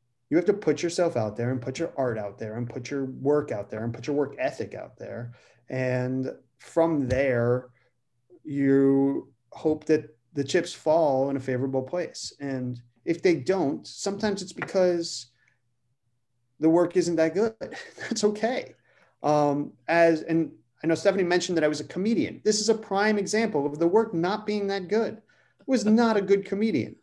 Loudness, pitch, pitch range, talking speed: -26 LUFS, 150 Hz, 130-185 Hz, 185 wpm